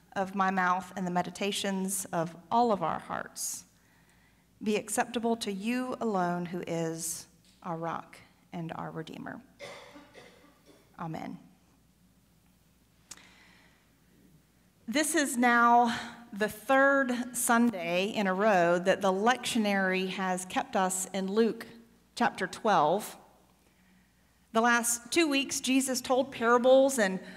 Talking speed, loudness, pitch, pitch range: 110 wpm, -29 LUFS, 215 Hz, 185-245 Hz